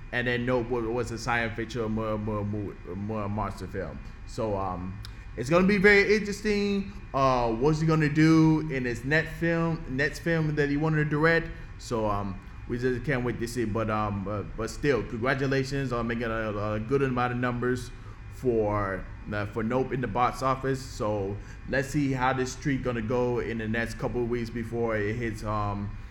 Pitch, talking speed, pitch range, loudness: 120 Hz, 195 wpm, 105-135 Hz, -28 LUFS